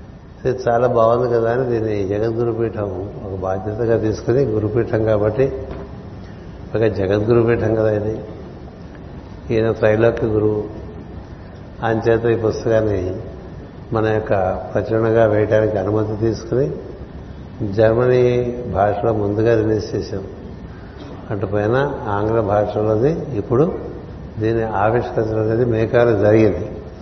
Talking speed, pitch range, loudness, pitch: 95 wpm, 100-115 Hz, -18 LUFS, 110 Hz